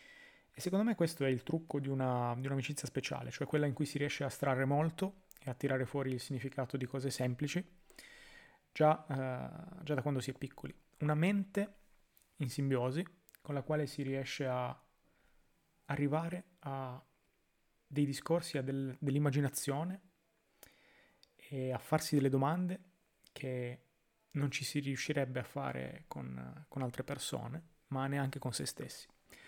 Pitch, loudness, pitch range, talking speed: 140 Hz, -38 LUFS, 135-165 Hz, 155 wpm